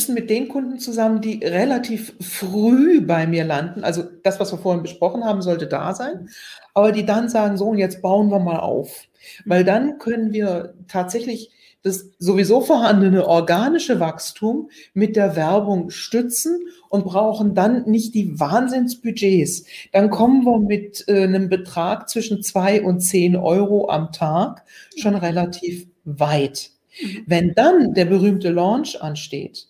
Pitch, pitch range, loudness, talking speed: 200 Hz, 175-225 Hz, -19 LUFS, 145 wpm